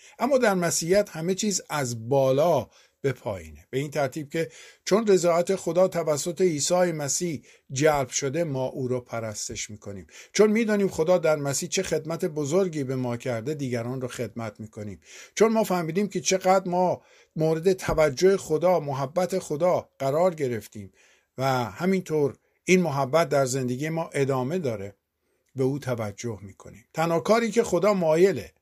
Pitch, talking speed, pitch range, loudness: 155 Hz, 150 wpm, 125-180 Hz, -25 LUFS